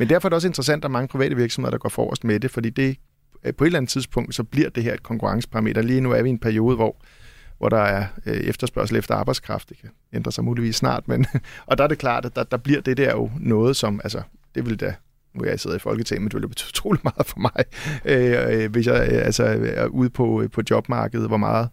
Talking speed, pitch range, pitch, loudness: 260 wpm, 110-135 Hz, 120 Hz, -22 LUFS